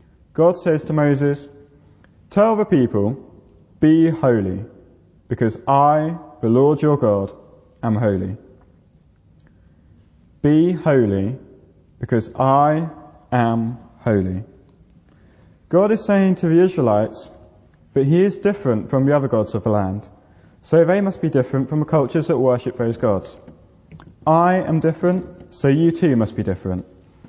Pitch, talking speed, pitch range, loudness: 125 Hz, 135 wpm, 100-155 Hz, -18 LUFS